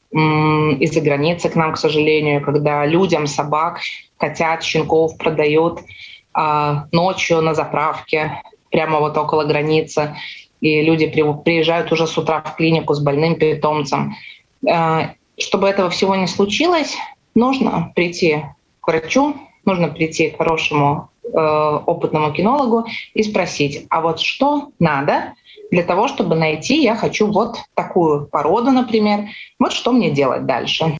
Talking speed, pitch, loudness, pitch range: 130 wpm, 160 Hz, -17 LUFS, 155-195 Hz